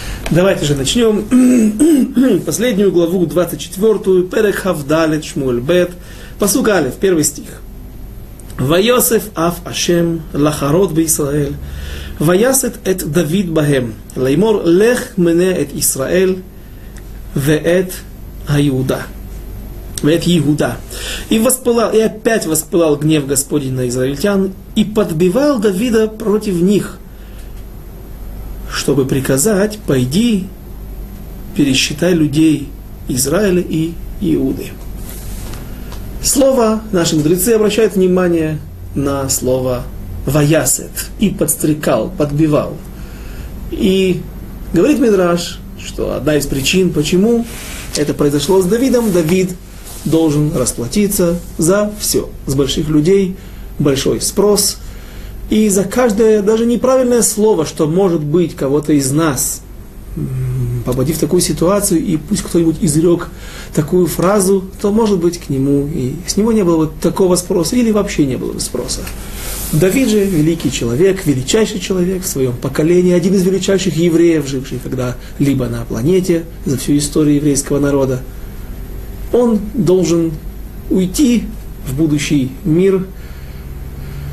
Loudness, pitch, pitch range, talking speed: -14 LUFS, 170 Hz, 140-195 Hz, 110 wpm